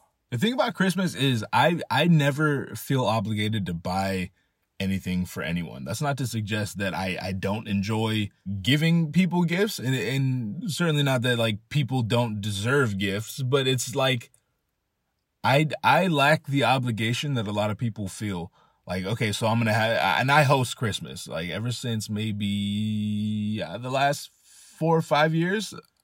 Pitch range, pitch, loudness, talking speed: 105-145 Hz, 120 Hz, -25 LUFS, 165 wpm